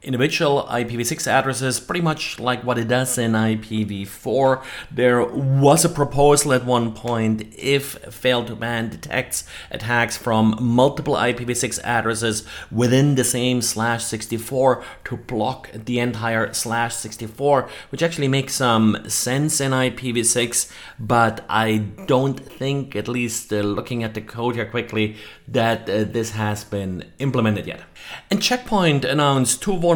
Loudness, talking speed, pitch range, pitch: -20 LUFS, 145 wpm, 110-135 Hz, 120 Hz